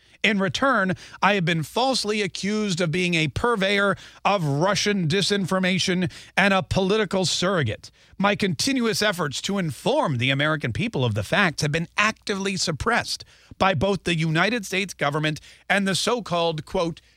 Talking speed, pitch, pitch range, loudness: 155 wpm, 190 Hz, 160-205 Hz, -23 LUFS